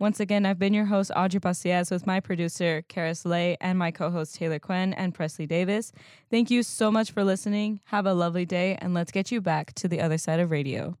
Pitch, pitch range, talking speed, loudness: 180 Hz, 170-200 Hz, 230 wpm, -26 LUFS